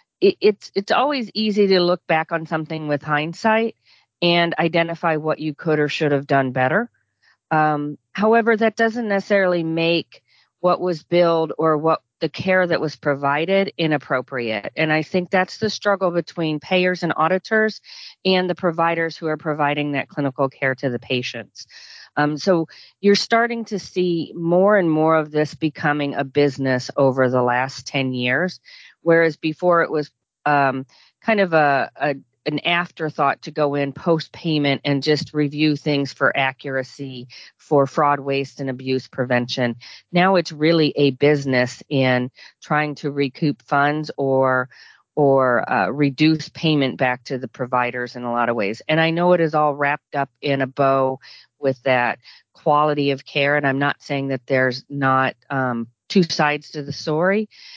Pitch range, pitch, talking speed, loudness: 135-170 Hz, 150 Hz, 165 wpm, -20 LUFS